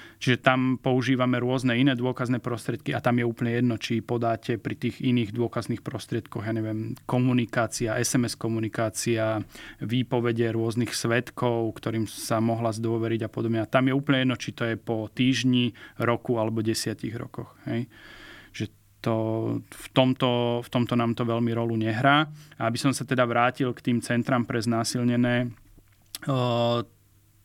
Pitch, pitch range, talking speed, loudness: 120 Hz, 115-125 Hz, 155 wpm, -26 LUFS